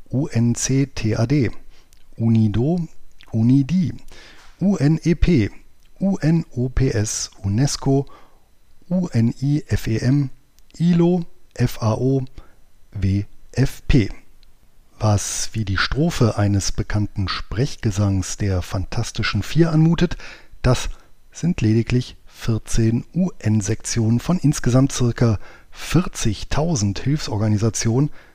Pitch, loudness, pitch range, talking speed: 115 Hz, -20 LUFS, 105-140 Hz, 65 wpm